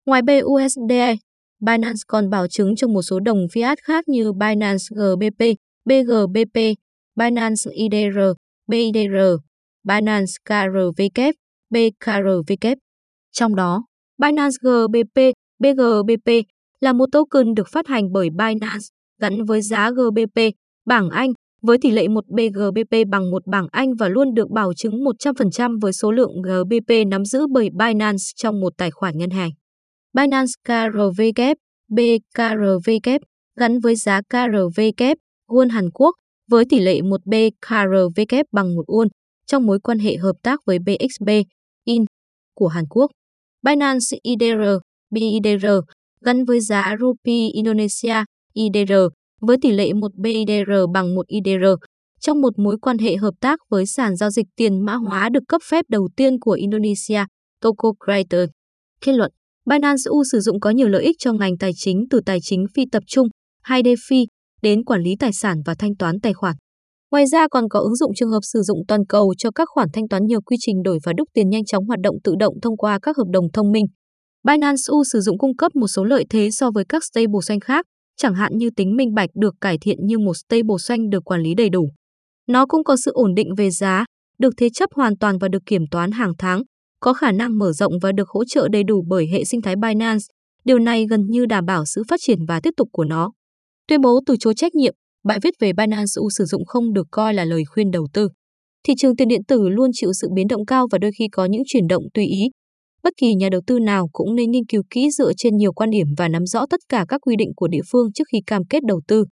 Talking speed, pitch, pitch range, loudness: 200 wpm, 220 Hz, 200-245 Hz, -18 LUFS